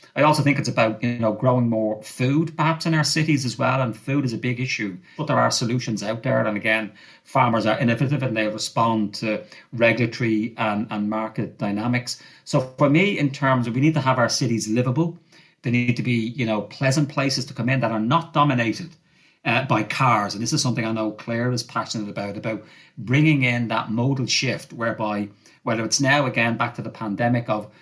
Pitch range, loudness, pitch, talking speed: 110-140 Hz, -22 LUFS, 120 Hz, 215 wpm